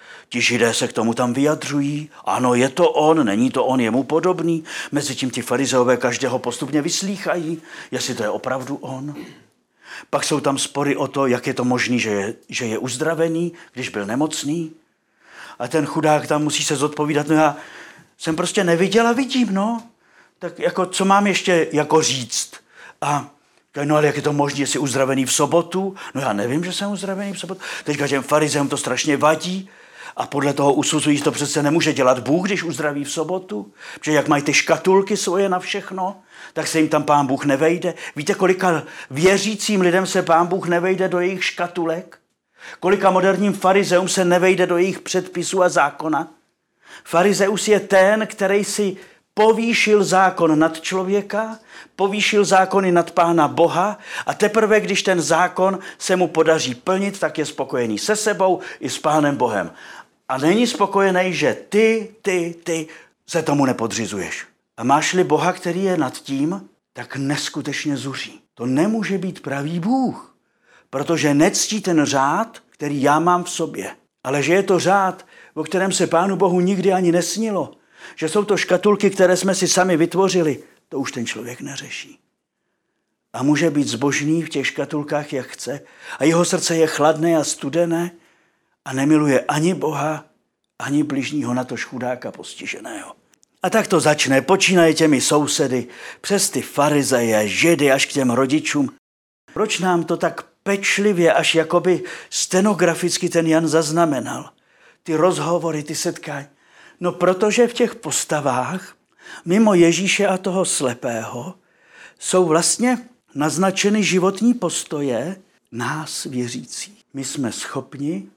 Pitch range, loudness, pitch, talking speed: 145-190 Hz, -19 LUFS, 165 Hz, 155 wpm